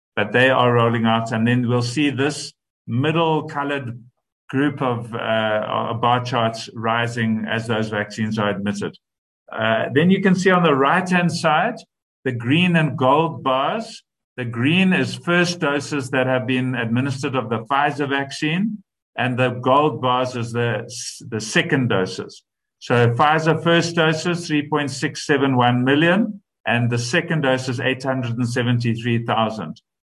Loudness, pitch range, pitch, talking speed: -20 LUFS, 120-155 Hz, 130 Hz, 145 wpm